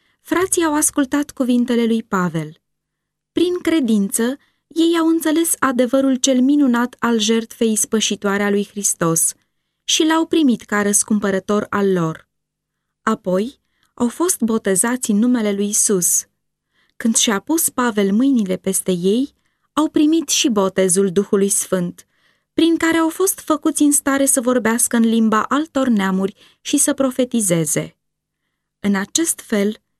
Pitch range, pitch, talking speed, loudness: 205-290 Hz, 235 Hz, 135 wpm, -17 LUFS